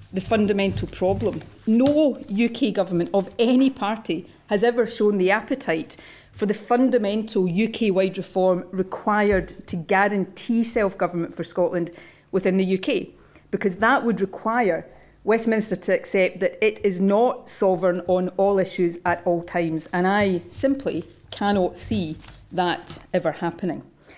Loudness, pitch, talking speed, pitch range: -22 LUFS, 195 Hz, 140 wpm, 180-220 Hz